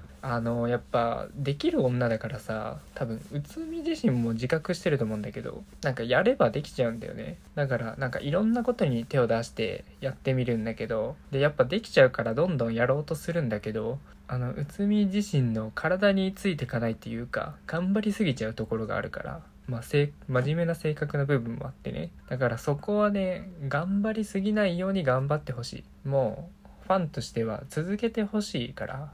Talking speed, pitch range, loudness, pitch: 400 characters per minute, 120-185 Hz, -29 LUFS, 140 Hz